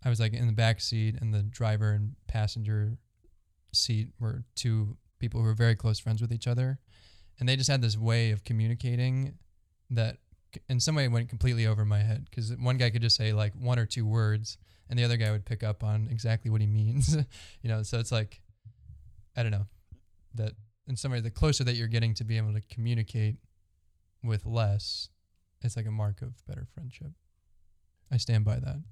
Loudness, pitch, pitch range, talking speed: -30 LUFS, 110 Hz, 105-120 Hz, 205 wpm